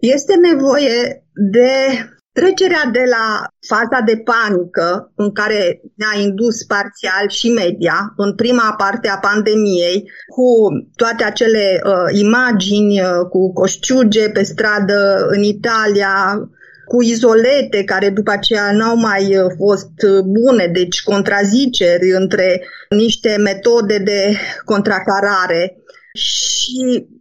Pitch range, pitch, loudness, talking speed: 195-235 Hz, 210 Hz, -14 LUFS, 110 wpm